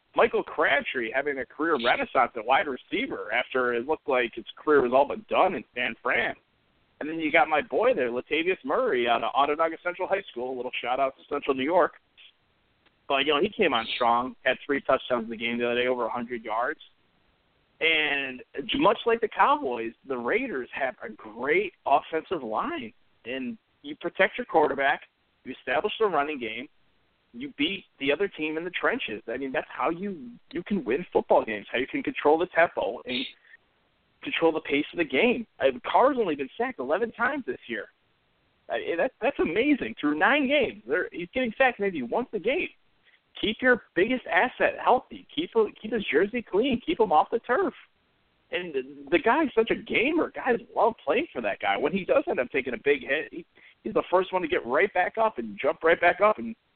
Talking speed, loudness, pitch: 205 wpm, -26 LUFS, 200 Hz